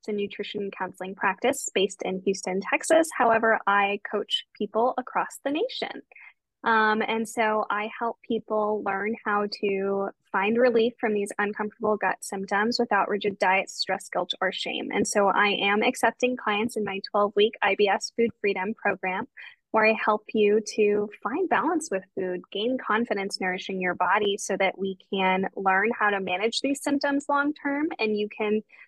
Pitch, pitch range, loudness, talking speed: 210 Hz, 200-230 Hz, -26 LUFS, 165 wpm